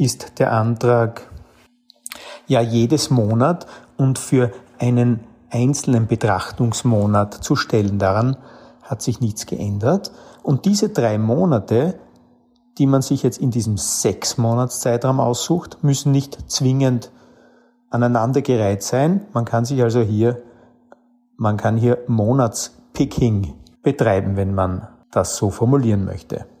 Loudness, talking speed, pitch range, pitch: -19 LUFS, 115 wpm, 115-135 Hz, 120 Hz